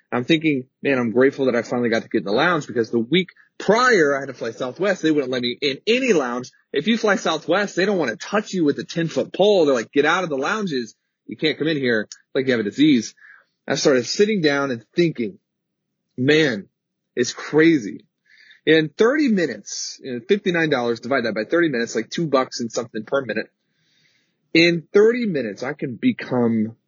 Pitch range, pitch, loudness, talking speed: 125-190 Hz, 155 Hz, -20 LUFS, 210 wpm